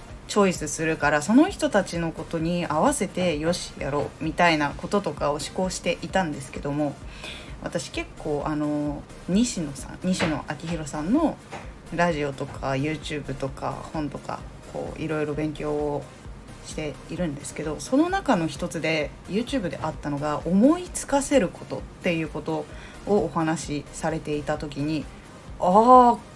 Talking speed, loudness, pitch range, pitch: 330 characters per minute, -25 LUFS, 150-180 Hz, 160 Hz